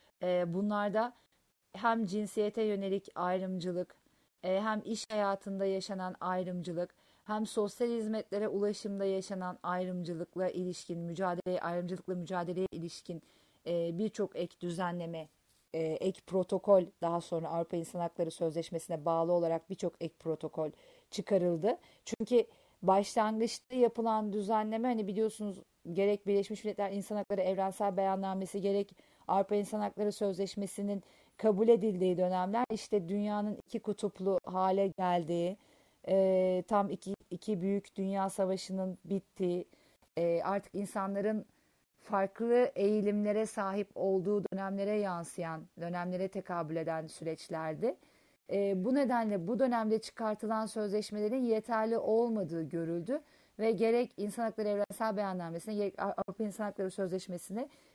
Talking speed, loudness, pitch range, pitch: 110 wpm, -34 LUFS, 180-215 Hz, 195 Hz